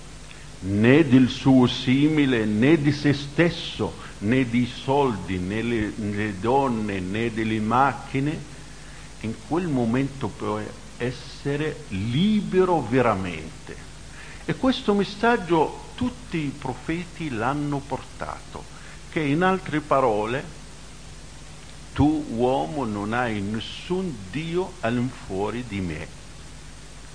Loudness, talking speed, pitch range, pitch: -24 LUFS, 100 wpm, 110-155 Hz, 130 Hz